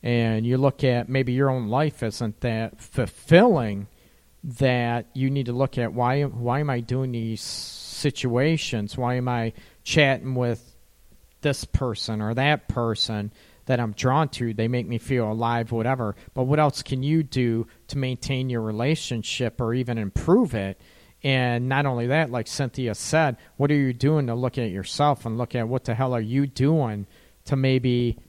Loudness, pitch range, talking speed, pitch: -24 LUFS, 115-135 Hz, 180 wpm, 125 Hz